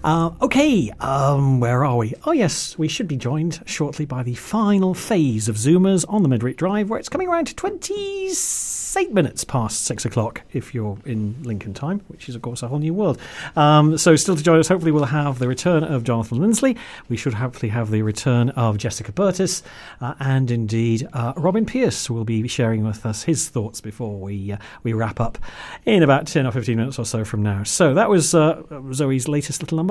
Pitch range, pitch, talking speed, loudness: 115-170 Hz, 140 Hz, 215 wpm, -20 LUFS